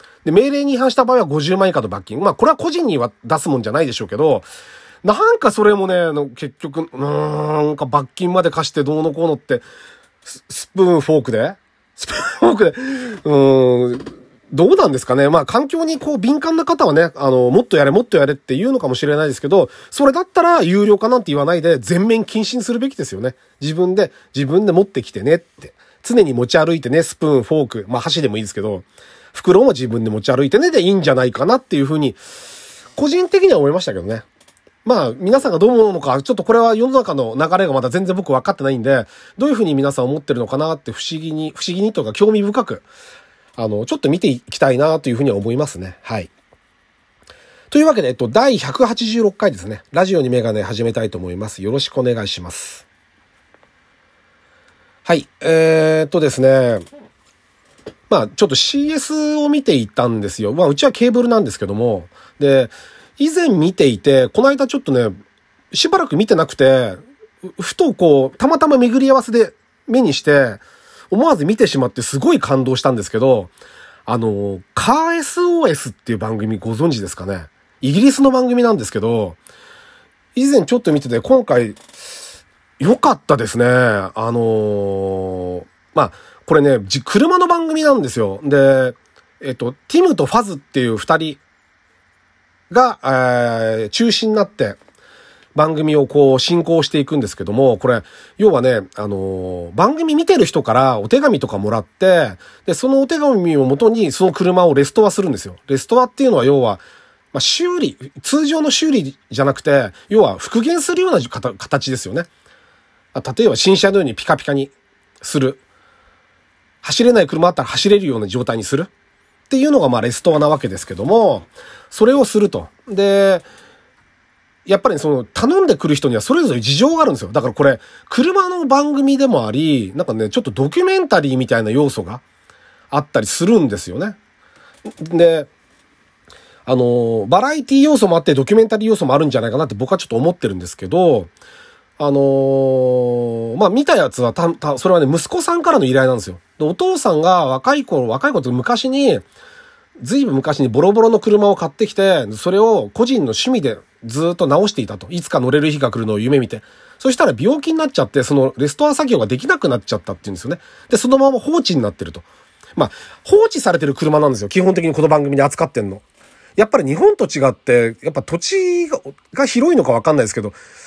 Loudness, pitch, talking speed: -15 LUFS, 160 Hz, 385 characters per minute